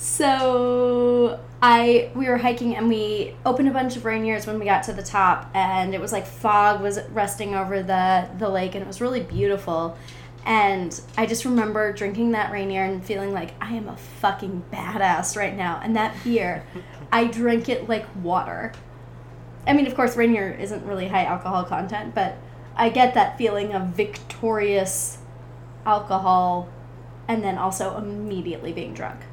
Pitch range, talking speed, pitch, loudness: 185-230 Hz, 170 wpm, 205 Hz, -23 LUFS